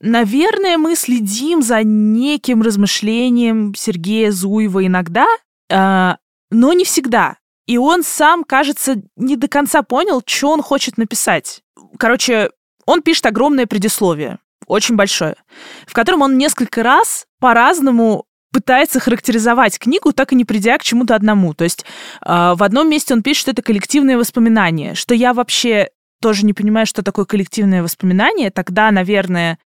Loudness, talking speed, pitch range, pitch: -14 LUFS, 140 wpm, 205-270 Hz, 235 Hz